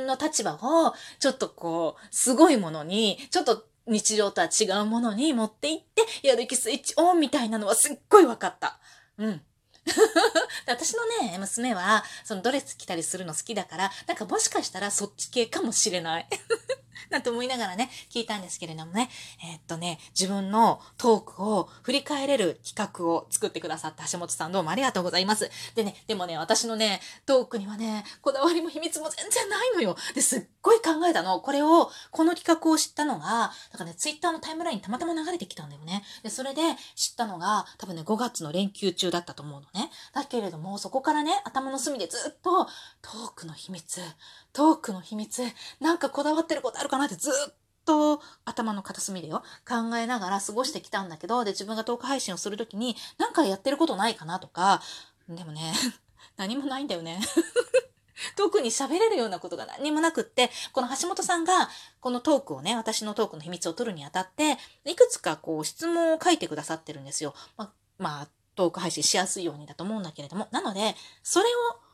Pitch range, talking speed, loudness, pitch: 185-300 Hz, 405 characters per minute, -27 LUFS, 230 Hz